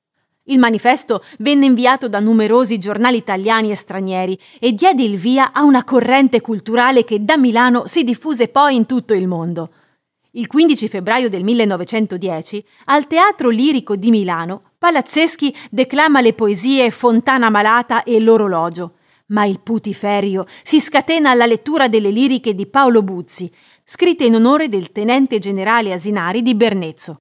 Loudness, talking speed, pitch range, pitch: -14 LUFS, 150 wpm, 205-260 Hz, 230 Hz